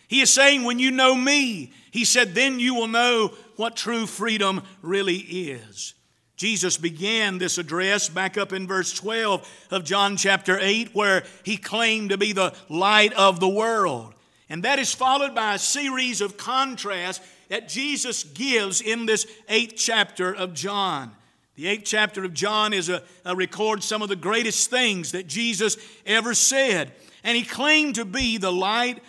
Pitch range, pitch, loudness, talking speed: 190-235 Hz, 210 Hz, -22 LUFS, 175 wpm